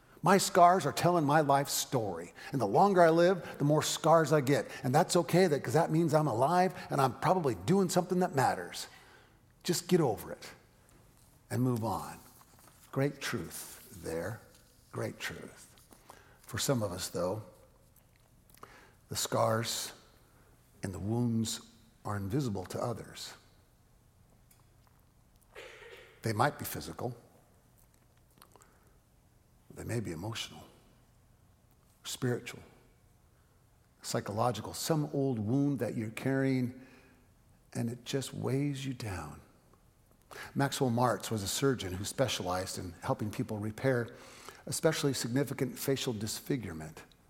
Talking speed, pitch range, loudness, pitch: 120 wpm, 115-155 Hz, -32 LUFS, 130 Hz